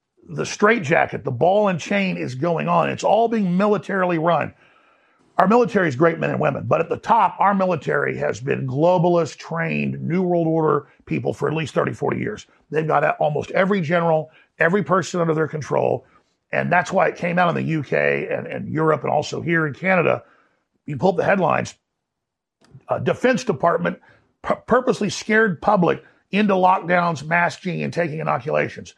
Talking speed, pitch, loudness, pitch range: 175 wpm, 175 Hz, -20 LUFS, 160-195 Hz